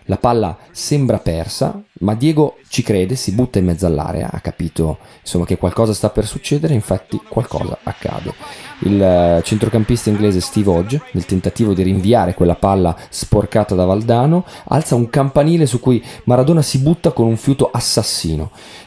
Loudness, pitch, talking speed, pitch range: -16 LUFS, 110 Hz, 160 wpm, 90-130 Hz